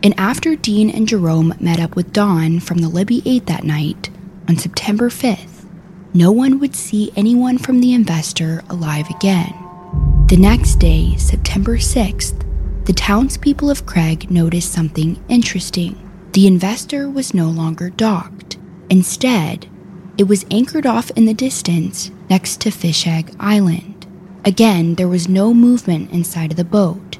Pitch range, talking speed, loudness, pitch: 170-210 Hz, 150 wpm, -15 LUFS, 185 Hz